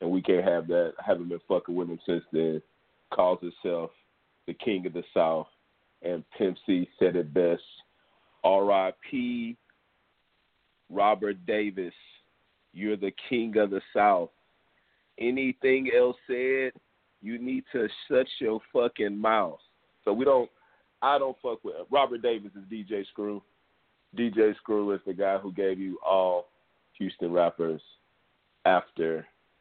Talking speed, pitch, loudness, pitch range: 140 wpm, 100 Hz, -28 LUFS, 90-130 Hz